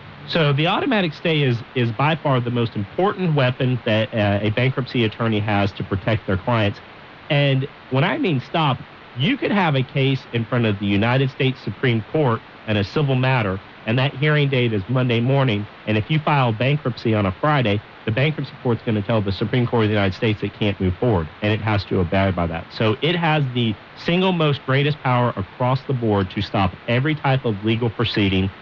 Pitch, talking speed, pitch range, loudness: 120 Hz, 210 wpm, 105-140 Hz, -20 LUFS